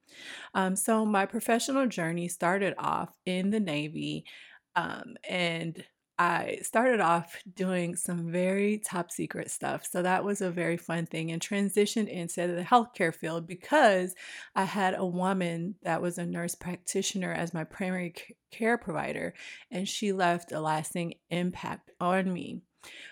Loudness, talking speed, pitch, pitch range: -30 LUFS, 150 wpm, 180 Hz, 170-200 Hz